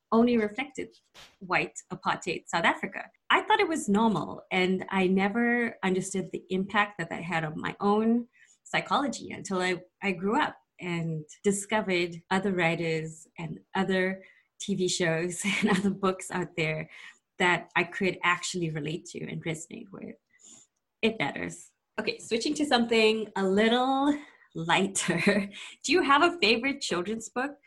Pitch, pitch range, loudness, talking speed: 195 Hz, 180-225 Hz, -28 LUFS, 145 wpm